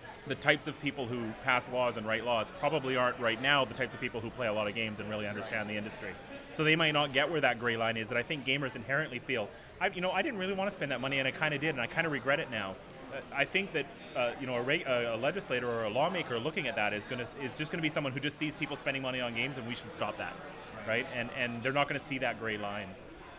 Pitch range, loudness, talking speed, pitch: 115-145 Hz, -33 LUFS, 300 wpm, 130 Hz